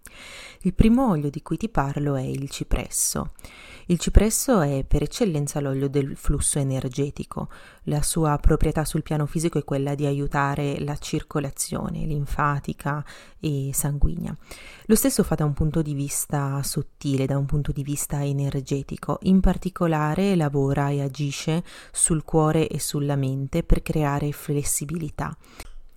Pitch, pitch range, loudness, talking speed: 145 Hz, 140-160 Hz, -24 LUFS, 145 wpm